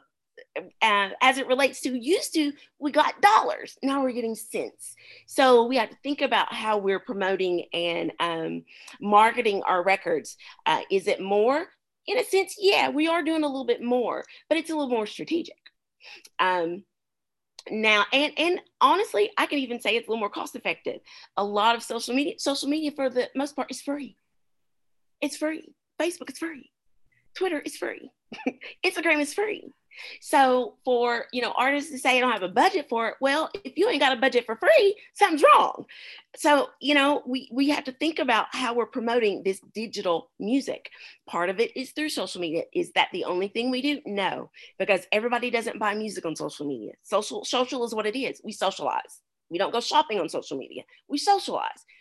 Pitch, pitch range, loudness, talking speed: 265 Hz, 220-310 Hz, -25 LUFS, 195 wpm